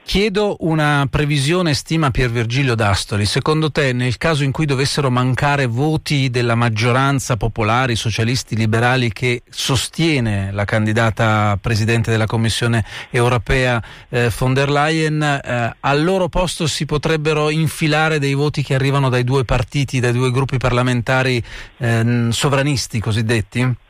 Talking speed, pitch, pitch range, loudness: 135 wpm, 130 Hz, 115-145 Hz, -17 LUFS